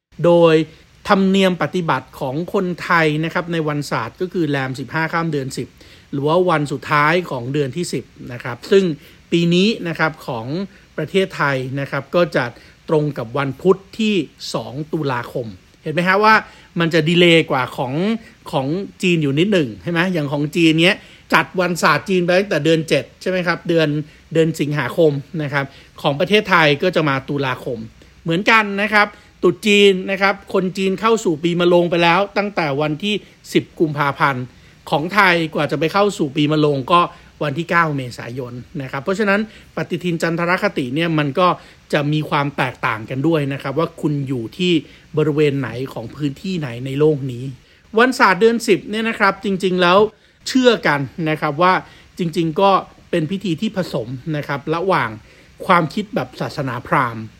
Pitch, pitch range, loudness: 165 Hz, 145-185 Hz, -18 LUFS